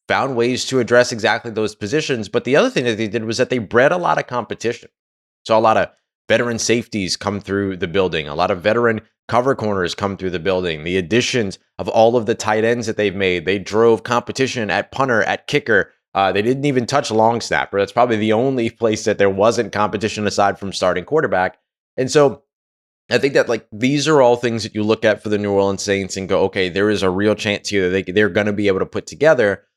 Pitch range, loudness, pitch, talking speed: 100-120 Hz, -18 LUFS, 110 Hz, 235 wpm